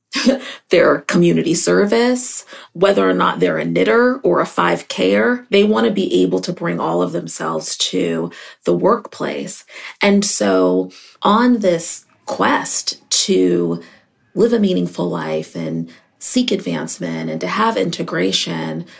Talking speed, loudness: 135 wpm, -16 LUFS